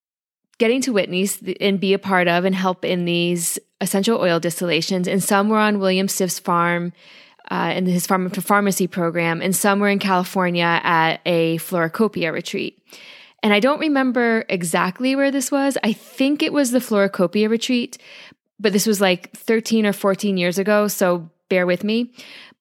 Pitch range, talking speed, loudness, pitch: 180-220 Hz, 175 wpm, -19 LUFS, 195 Hz